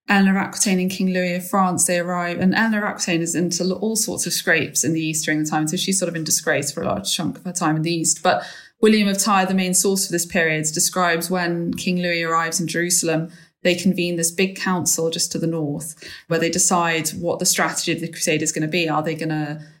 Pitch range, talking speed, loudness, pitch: 165-185 Hz, 250 wpm, -20 LUFS, 175 Hz